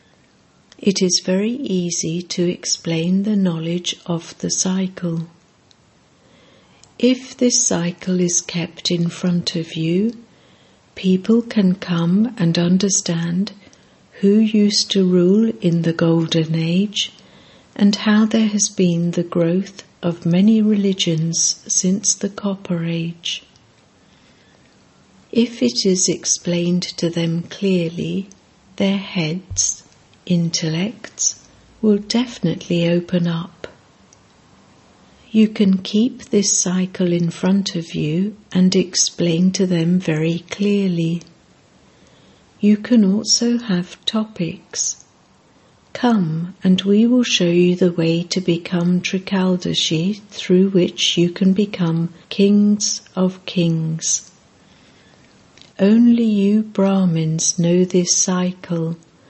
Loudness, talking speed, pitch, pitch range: -18 LUFS, 105 wpm, 185 Hz, 170-205 Hz